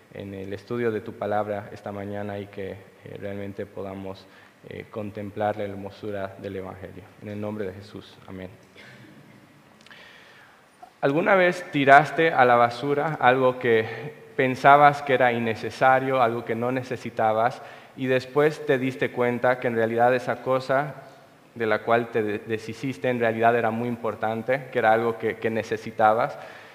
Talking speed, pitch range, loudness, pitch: 145 wpm, 105-130 Hz, -23 LUFS, 115 Hz